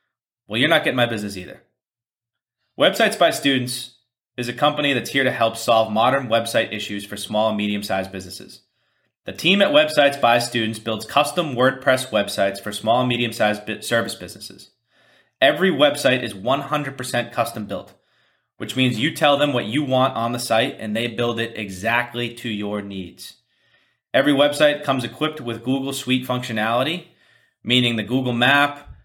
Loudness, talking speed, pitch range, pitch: -20 LUFS, 165 wpm, 110-135 Hz, 120 Hz